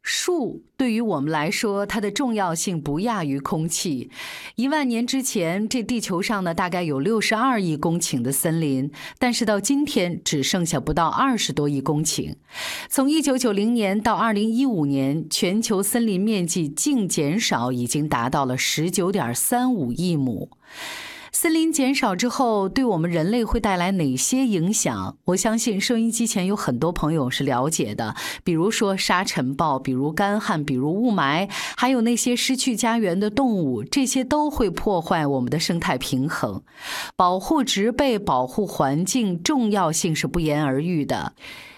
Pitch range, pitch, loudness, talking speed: 155-235 Hz, 195 Hz, -22 LUFS, 255 characters per minute